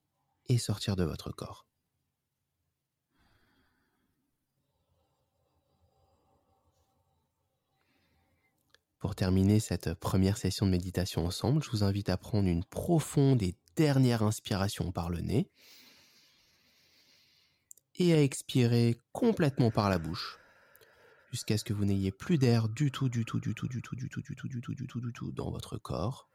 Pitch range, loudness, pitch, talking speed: 95-130 Hz, -31 LUFS, 110 Hz, 140 wpm